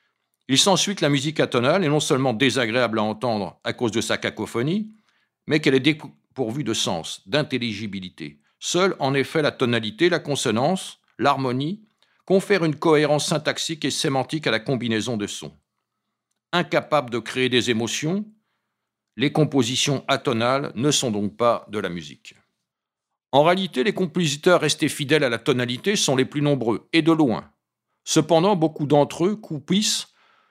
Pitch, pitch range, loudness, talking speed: 145 Hz, 120-165 Hz, -22 LUFS, 155 wpm